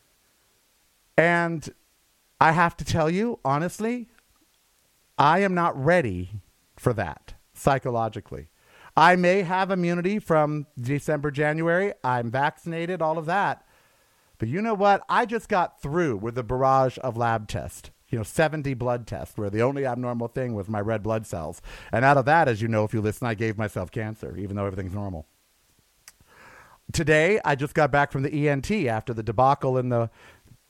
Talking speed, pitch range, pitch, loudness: 170 wpm, 110-165 Hz, 135 Hz, -24 LUFS